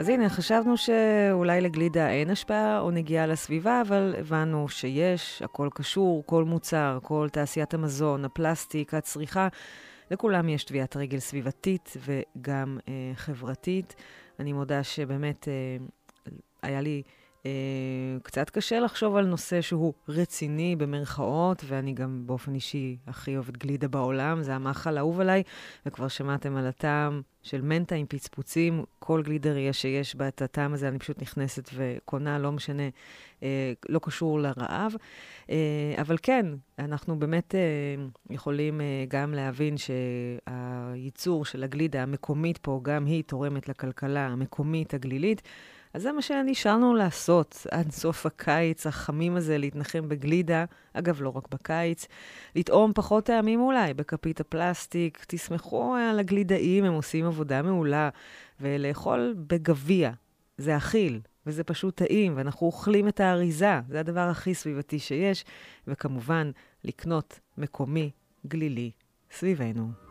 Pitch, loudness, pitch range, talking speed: 150 Hz, -28 LUFS, 135-170 Hz, 125 wpm